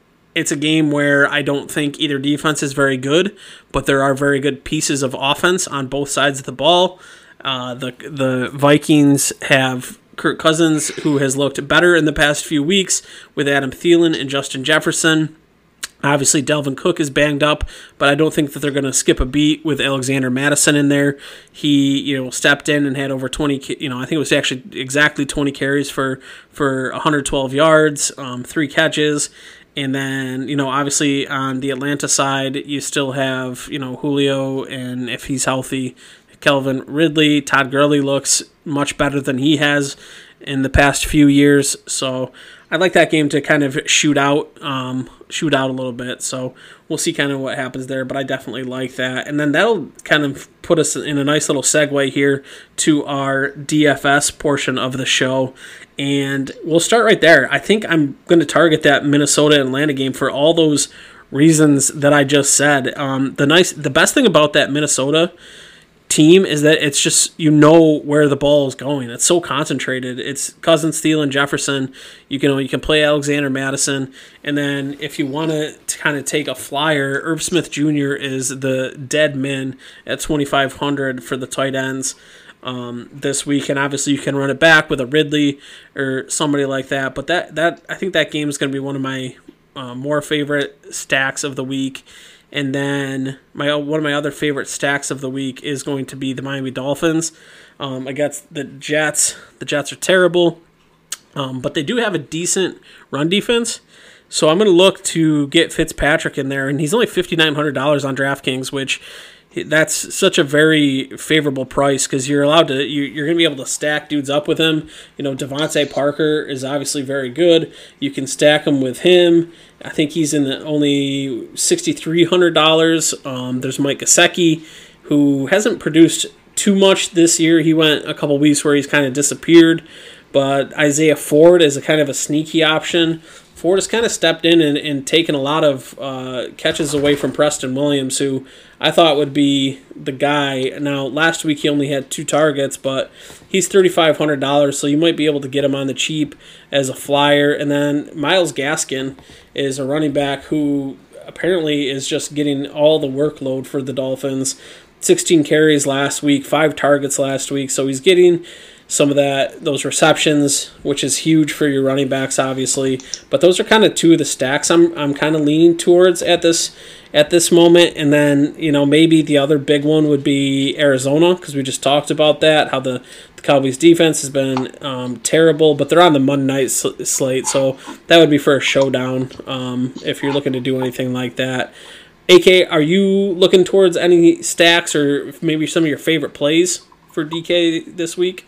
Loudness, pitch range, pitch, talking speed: -15 LUFS, 135-155 Hz, 145 Hz, 195 wpm